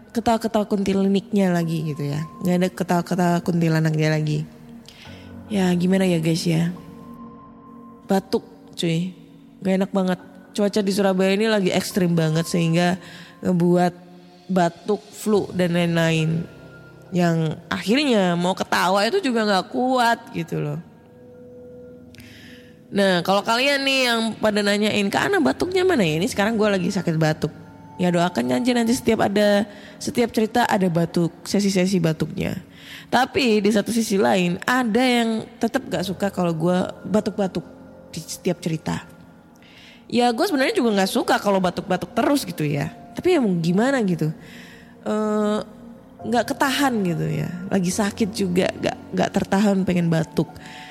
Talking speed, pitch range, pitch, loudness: 135 wpm, 170-220 Hz, 190 Hz, -21 LUFS